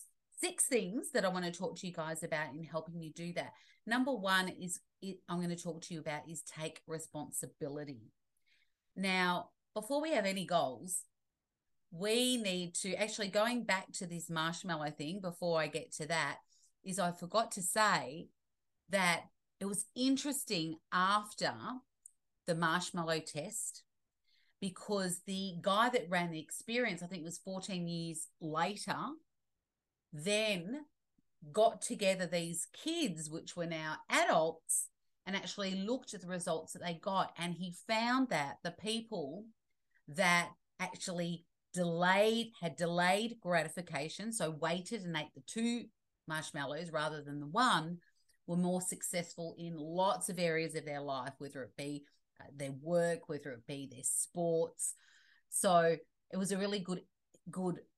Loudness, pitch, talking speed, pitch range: -37 LUFS, 175 Hz, 150 wpm, 160-200 Hz